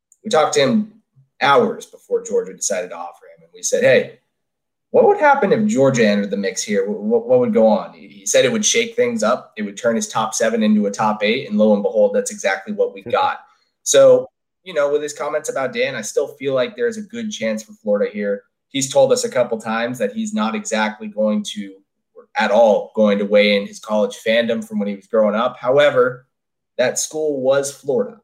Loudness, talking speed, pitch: -18 LUFS, 225 wpm, 155 Hz